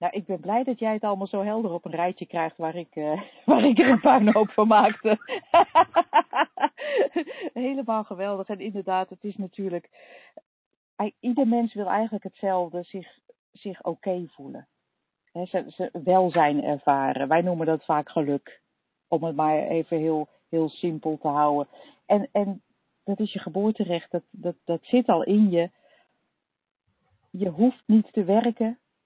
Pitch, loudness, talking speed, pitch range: 195 Hz, -24 LUFS, 165 wpm, 170-220 Hz